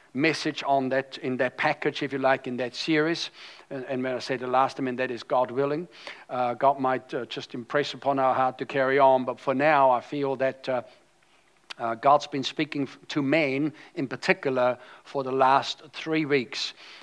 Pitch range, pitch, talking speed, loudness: 130-145 Hz, 135 Hz, 195 wpm, -26 LUFS